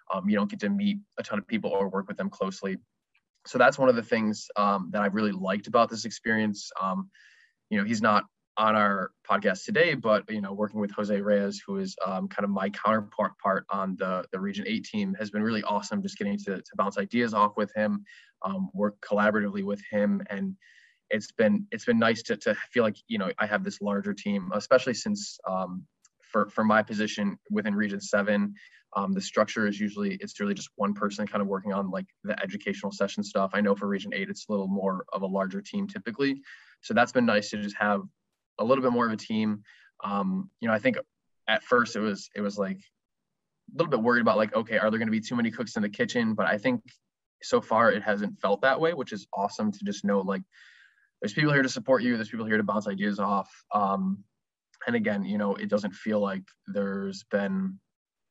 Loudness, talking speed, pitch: -28 LUFS, 230 wpm, 105 Hz